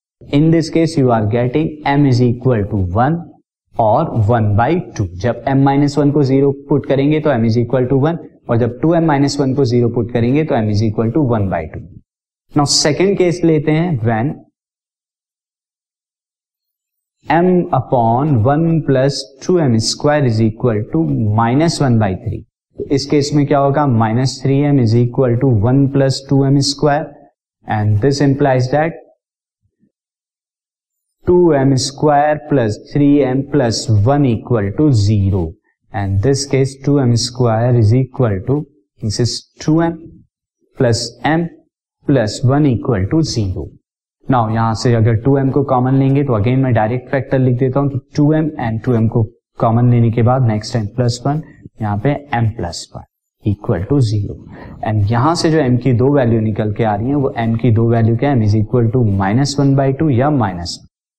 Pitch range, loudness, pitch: 115-145 Hz, -15 LUFS, 130 Hz